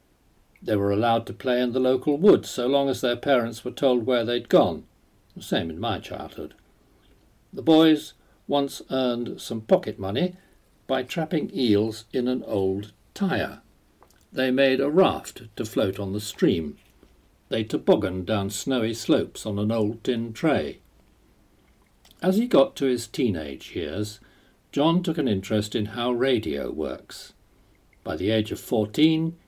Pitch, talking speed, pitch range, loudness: 125 Hz, 155 wpm, 105-140 Hz, -24 LUFS